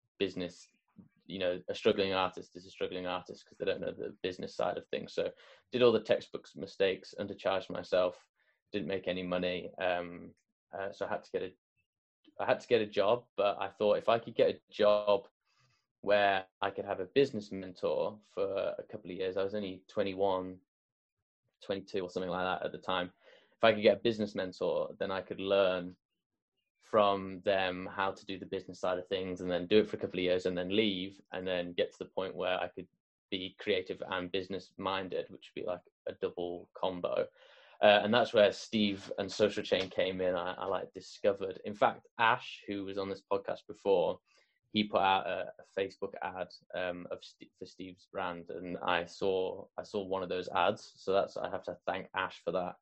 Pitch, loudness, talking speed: 100 Hz, -34 LUFS, 210 wpm